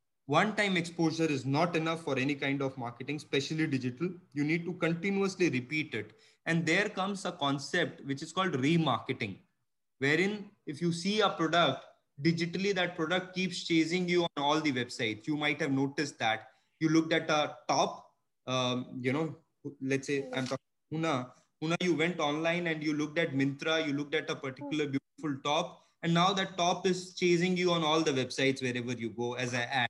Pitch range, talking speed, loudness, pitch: 135-170 Hz, 190 wpm, -31 LUFS, 155 Hz